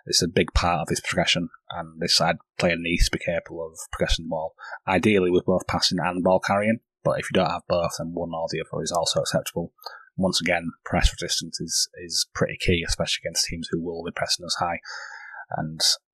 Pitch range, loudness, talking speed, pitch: 85-115 Hz, -24 LUFS, 215 wpm, 90 Hz